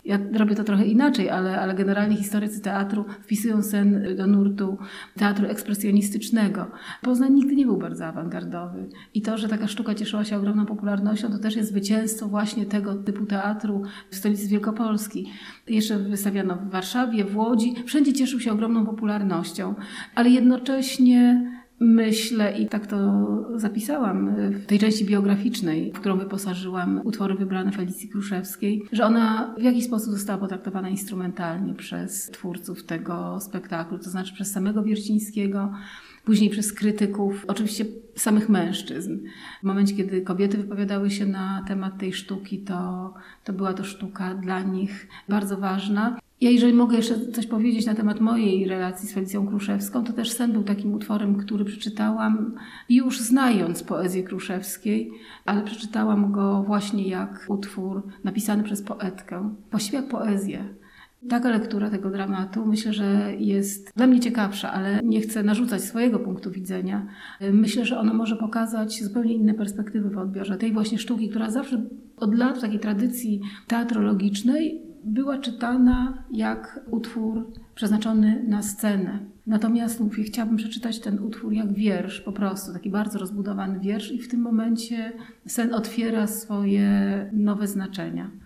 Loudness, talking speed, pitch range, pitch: -24 LUFS, 150 wpm, 195-225 Hz, 210 Hz